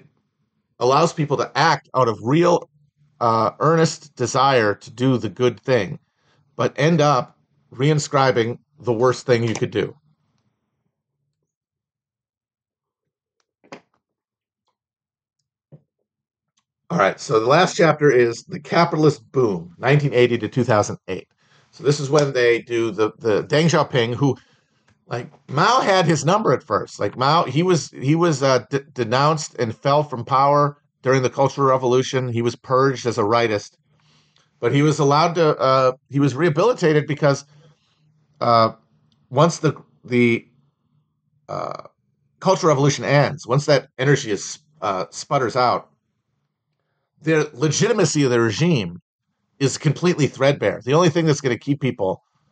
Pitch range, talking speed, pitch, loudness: 125-150 Hz, 140 wpm, 140 Hz, -19 LUFS